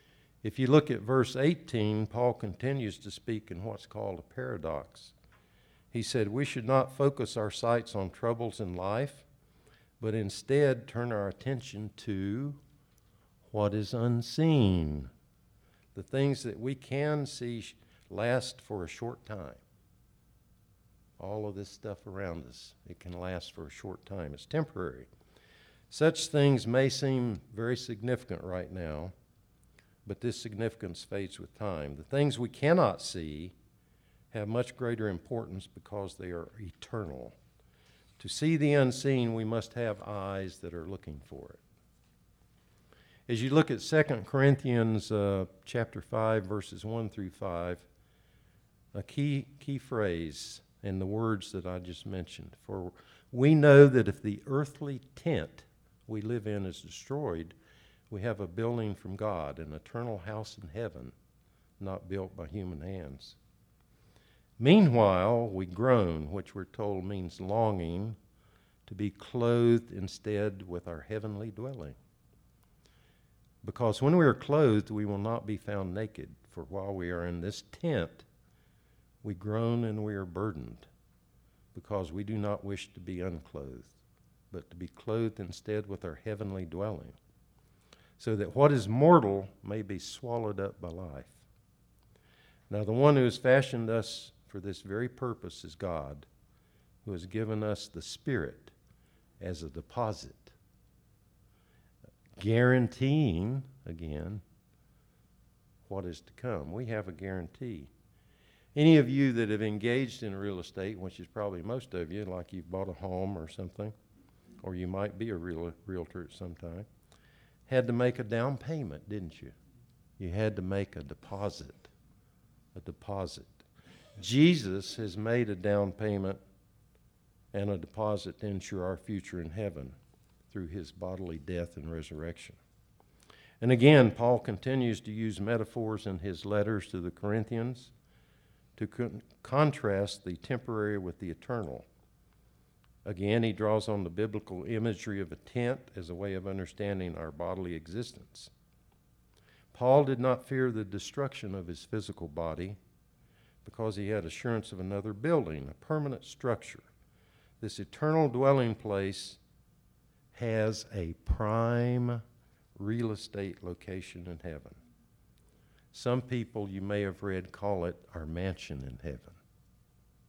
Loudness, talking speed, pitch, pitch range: -32 LUFS, 145 wpm, 105 Hz, 95-120 Hz